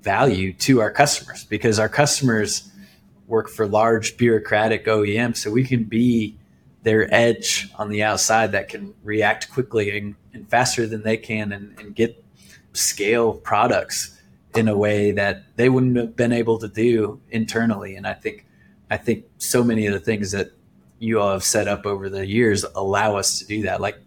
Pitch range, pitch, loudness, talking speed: 105-115 Hz, 110 Hz, -20 LUFS, 180 wpm